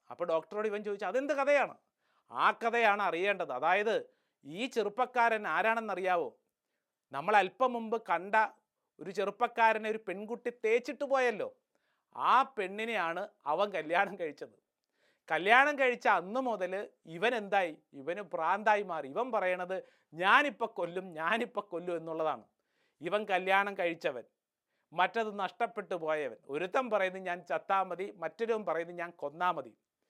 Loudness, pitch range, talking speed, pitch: -32 LUFS, 180-235 Hz, 120 wpm, 210 Hz